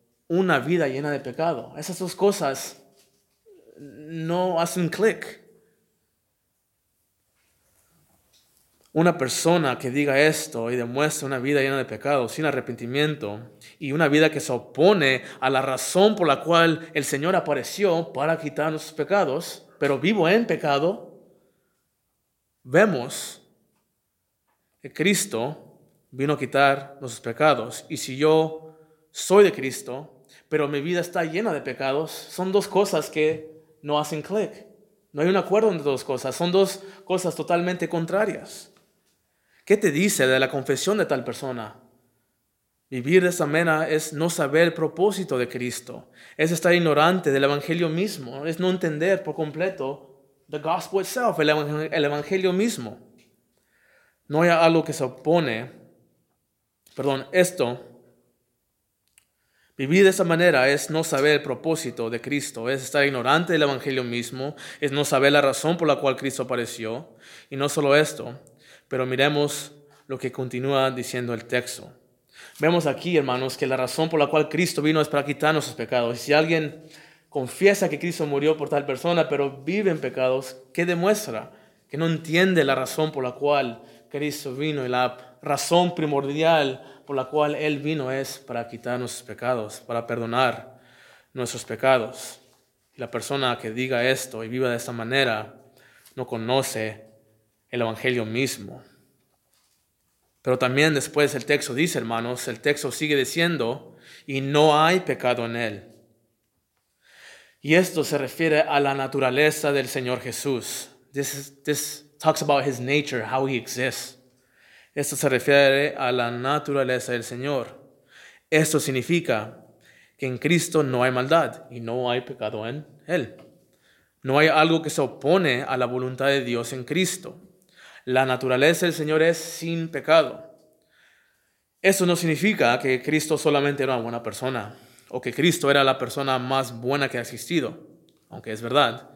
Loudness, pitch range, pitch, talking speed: -23 LUFS, 130-160 Hz, 145 Hz, 150 wpm